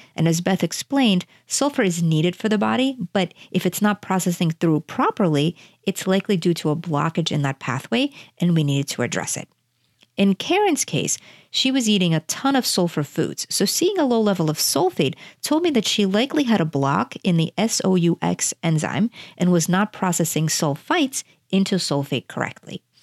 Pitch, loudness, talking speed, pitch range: 180 Hz, -21 LUFS, 180 wpm, 160-215 Hz